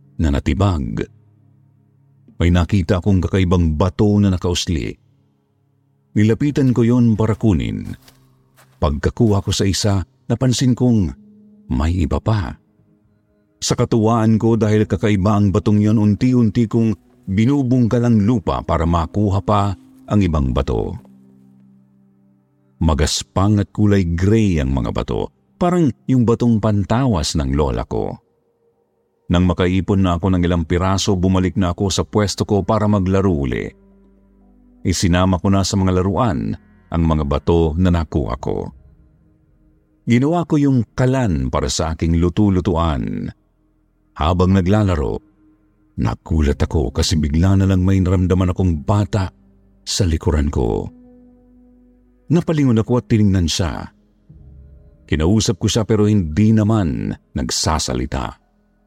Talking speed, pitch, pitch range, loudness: 120 wpm, 100 Hz, 85-110 Hz, -17 LUFS